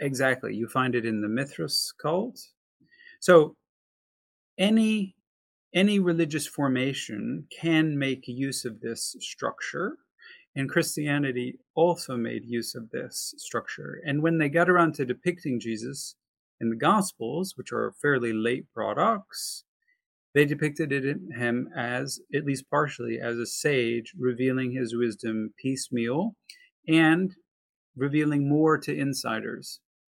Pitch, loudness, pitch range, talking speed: 140 Hz, -27 LUFS, 125-165 Hz, 130 wpm